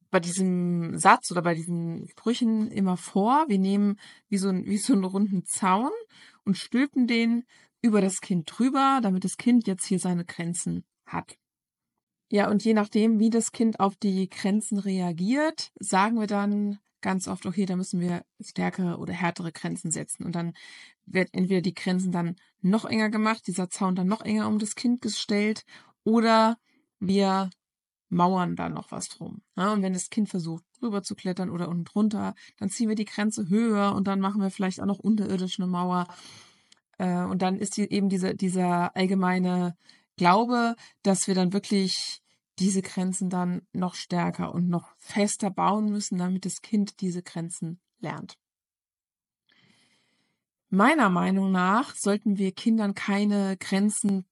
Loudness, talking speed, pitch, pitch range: -26 LUFS, 165 wpm, 195 Hz, 185-215 Hz